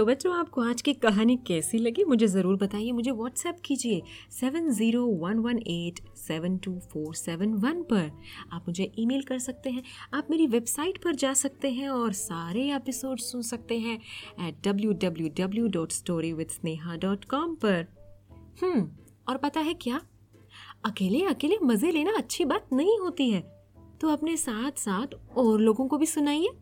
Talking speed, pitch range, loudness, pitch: 150 wpm, 185-275 Hz, -28 LUFS, 230 Hz